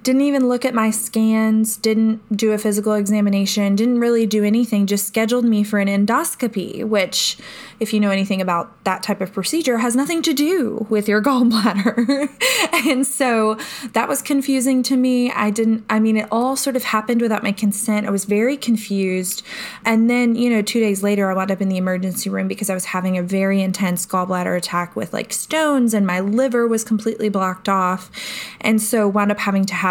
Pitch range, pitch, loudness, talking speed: 200-240 Hz, 215 Hz, -18 LUFS, 205 wpm